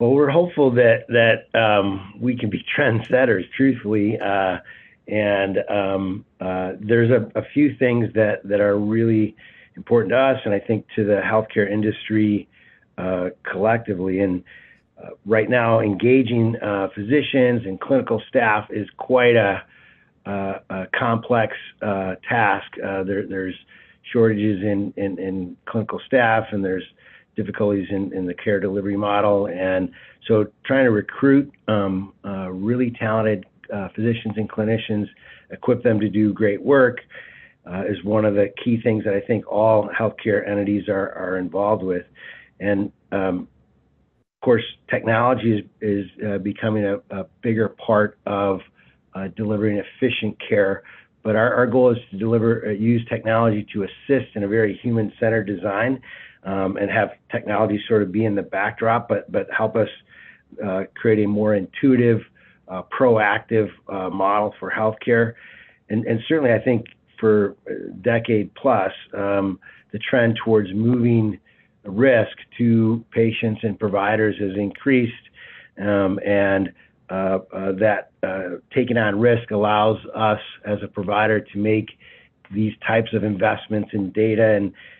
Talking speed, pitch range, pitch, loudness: 150 wpm, 100-115 Hz, 105 Hz, -21 LUFS